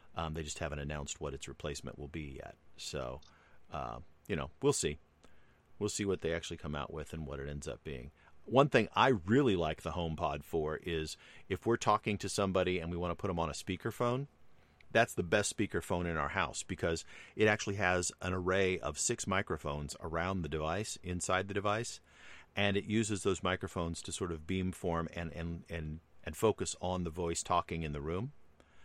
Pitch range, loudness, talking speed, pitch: 75-95 Hz, -35 LUFS, 205 wpm, 85 Hz